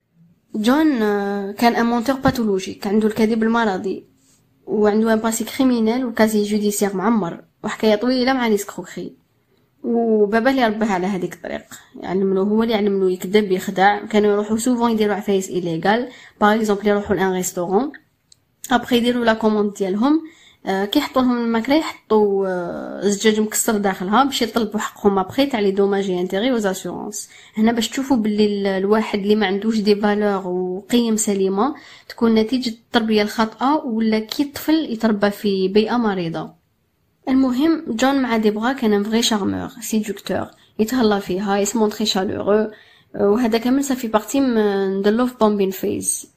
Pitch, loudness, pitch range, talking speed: 215 Hz, -19 LUFS, 200-235 Hz, 140 wpm